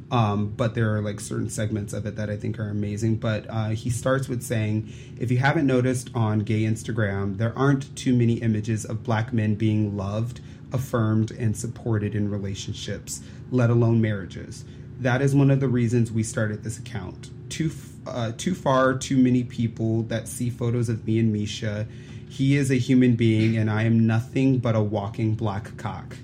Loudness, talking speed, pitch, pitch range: -24 LUFS, 190 wpm, 115 Hz, 110-125 Hz